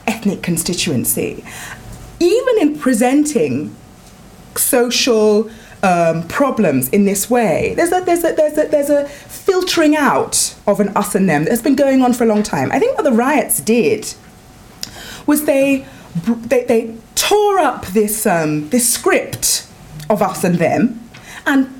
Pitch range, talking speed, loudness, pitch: 205-295 Hz, 150 wpm, -15 LUFS, 240 Hz